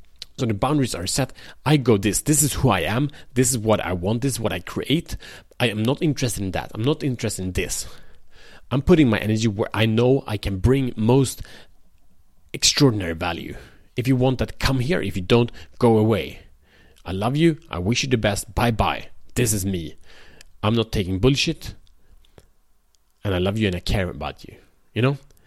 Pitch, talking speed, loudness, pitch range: 110 Hz, 205 wpm, -22 LUFS, 95-130 Hz